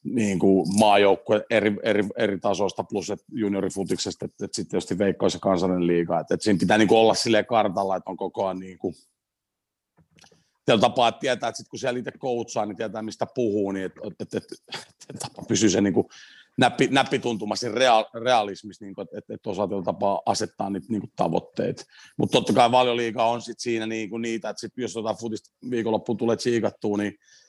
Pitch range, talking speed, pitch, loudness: 100-115 Hz, 200 wpm, 110 Hz, -24 LUFS